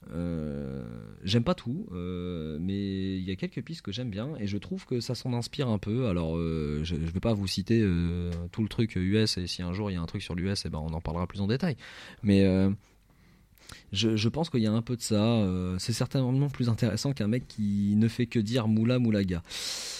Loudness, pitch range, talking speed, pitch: -29 LUFS, 90-115 Hz, 245 wpm, 100 Hz